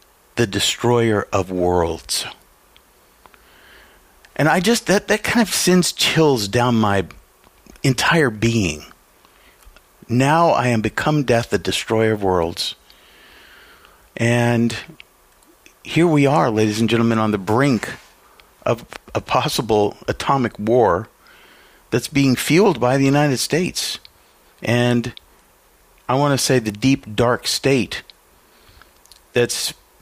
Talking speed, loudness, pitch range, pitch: 115 wpm, -18 LUFS, 105-140 Hz, 120 Hz